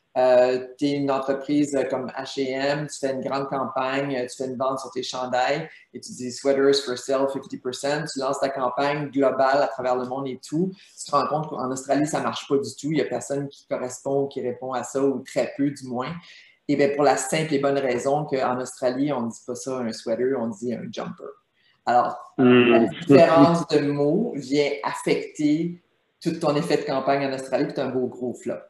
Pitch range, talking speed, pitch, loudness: 130-145 Hz, 215 wpm, 135 Hz, -24 LUFS